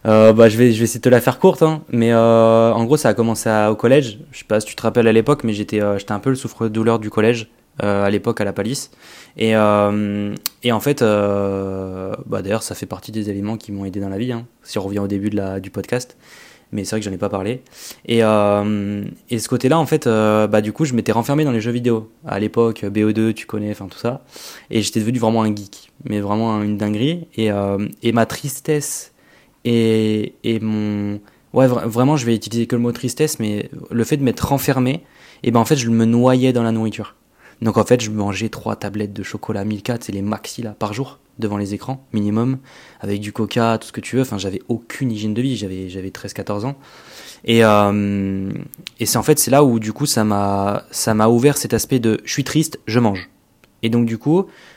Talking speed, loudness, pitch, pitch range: 245 wpm, -18 LUFS, 110 Hz, 105-120 Hz